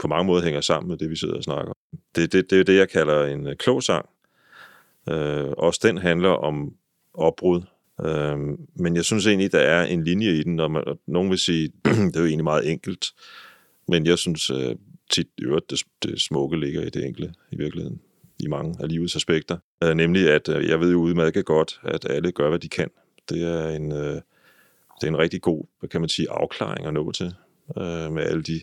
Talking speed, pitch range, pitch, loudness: 220 wpm, 75-85 Hz, 80 Hz, -23 LUFS